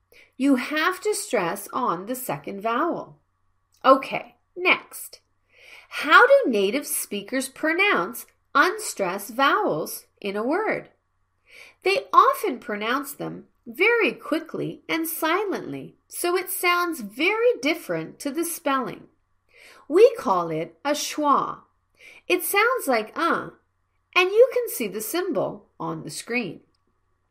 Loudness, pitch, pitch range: -23 LUFS, 315 Hz, 250-380 Hz